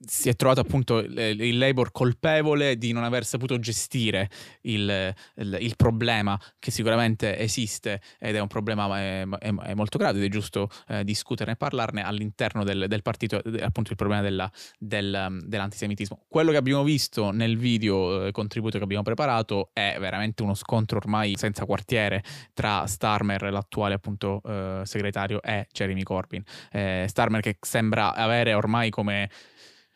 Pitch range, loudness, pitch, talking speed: 100-115 Hz, -26 LUFS, 105 Hz, 160 wpm